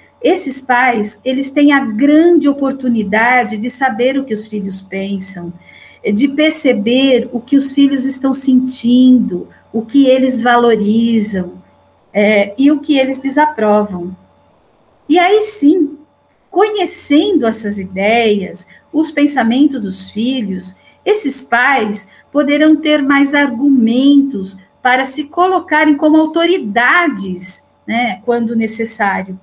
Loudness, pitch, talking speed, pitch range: -13 LUFS, 255 Hz, 115 wpm, 215-290 Hz